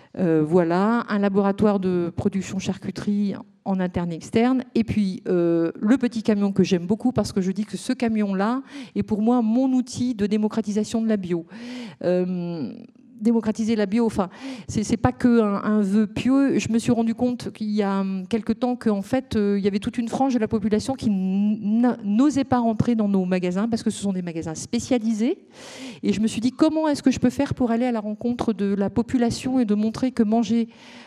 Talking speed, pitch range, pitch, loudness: 210 wpm, 200-245 Hz, 220 Hz, -23 LUFS